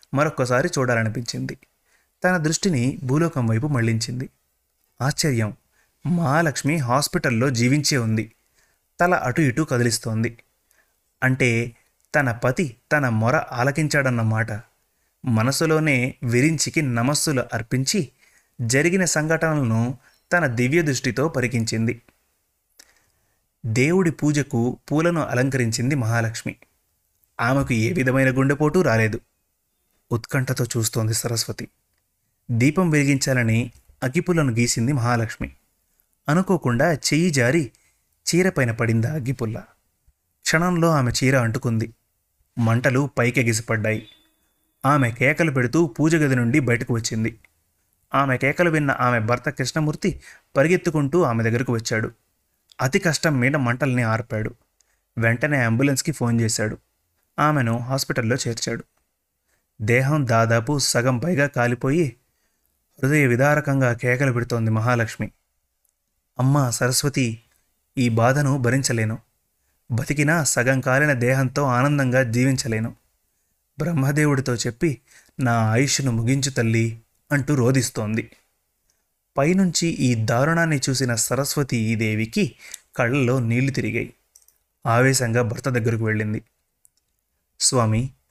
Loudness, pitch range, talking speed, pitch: -21 LUFS, 115-145 Hz, 95 wpm, 125 Hz